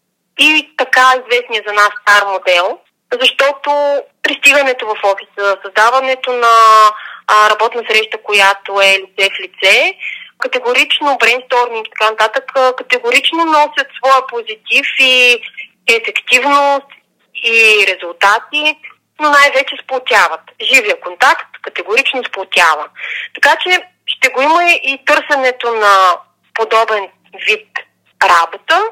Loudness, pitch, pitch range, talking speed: -11 LUFS, 255 Hz, 215-295 Hz, 105 wpm